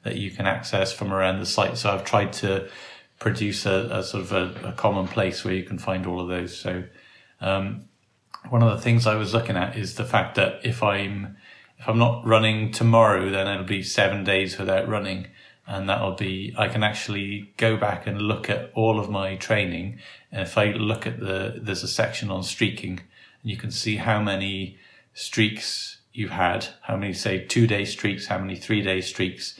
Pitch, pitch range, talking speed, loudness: 100 Hz, 95-110 Hz, 205 wpm, -24 LUFS